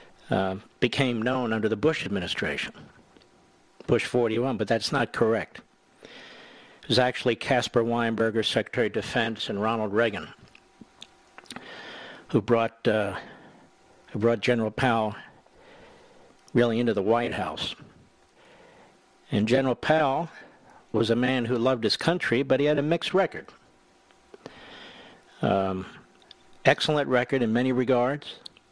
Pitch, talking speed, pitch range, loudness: 120 Hz, 120 wpm, 115-130 Hz, -26 LUFS